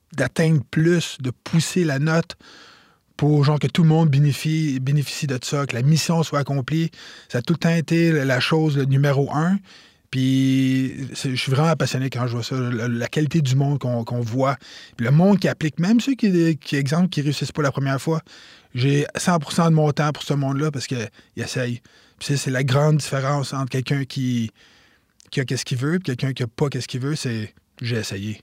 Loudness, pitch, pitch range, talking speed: -21 LUFS, 140 Hz, 130-155 Hz, 215 wpm